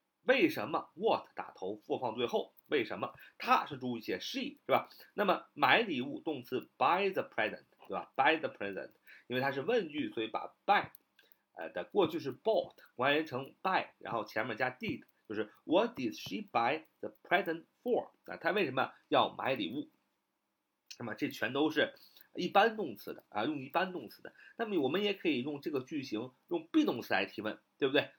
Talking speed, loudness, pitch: 380 characters per minute, -34 LUFS, 290 Hz